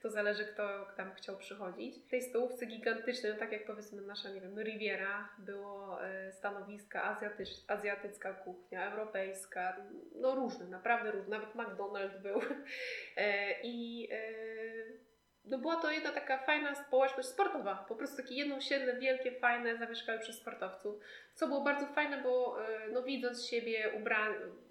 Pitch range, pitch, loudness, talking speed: 205-260 Hz, 225 Hz, -38 LUFS, 150 wpm